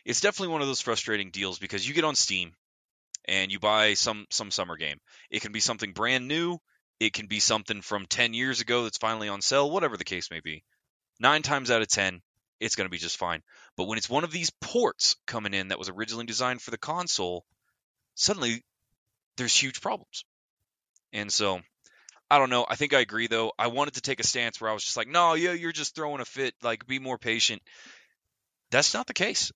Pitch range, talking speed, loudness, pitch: 105-135 Hz, 220 wpm, -27 LUFS, 115 Hz